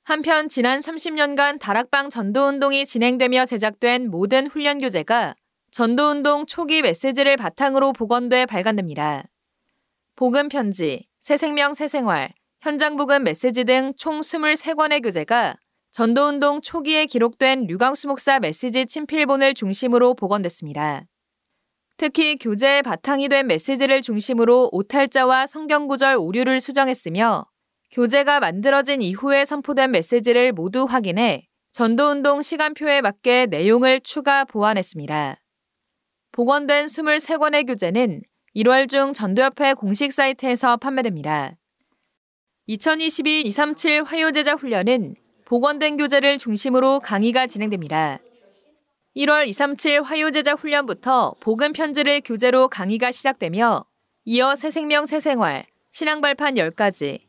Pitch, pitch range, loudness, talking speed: 270 Hz, 240-290 Hz, -19 LUFS, 285 characters per minute